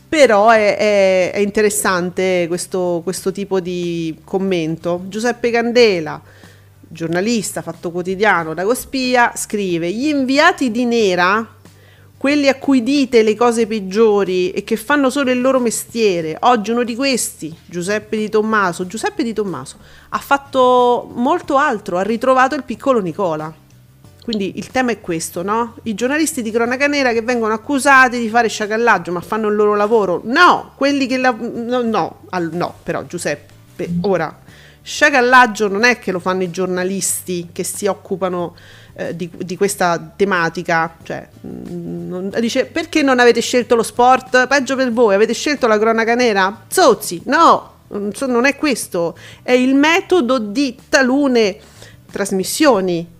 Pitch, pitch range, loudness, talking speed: 215 Hz, 180-250 Hz, -16 LUFS, 150 wpm